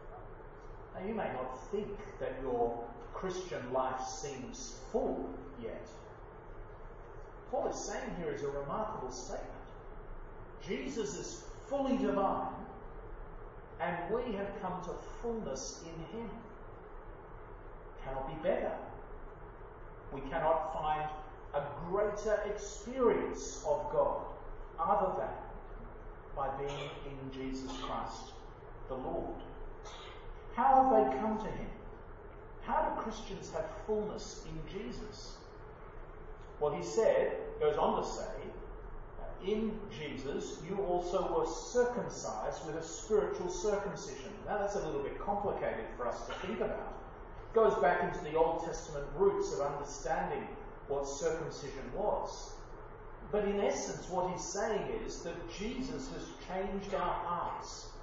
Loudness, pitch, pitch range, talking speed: -36 LUFS, 190 Hz, 155-215 Hz, 125 wpm